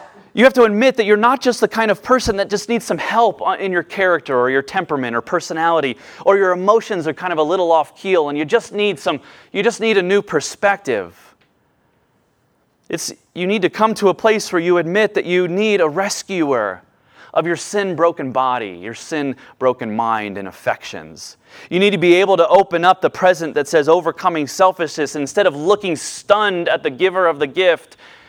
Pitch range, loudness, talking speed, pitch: 160-205 Hz, -17 LUFS, 205 wpm, 185 Hz